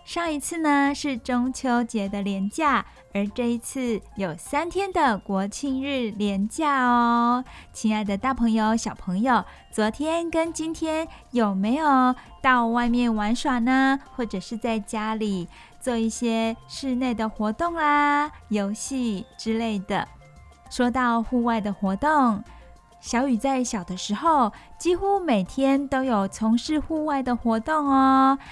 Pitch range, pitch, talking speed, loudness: 220-275 Hz, 245 Hz, 200 characters per minute, -24 LUFS